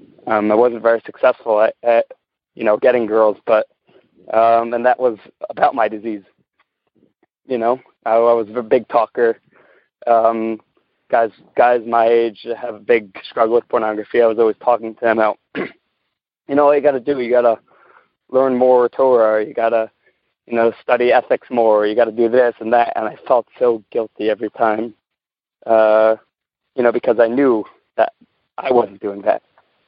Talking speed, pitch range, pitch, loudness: 175 wpm, 110-125 Hz, 115 Hz, -16 LUFS